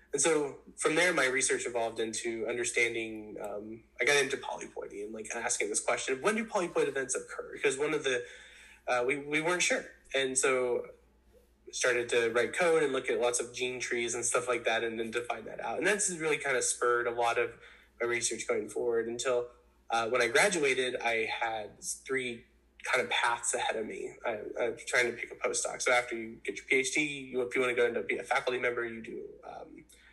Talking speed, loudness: 220 wpm, -31 LUFS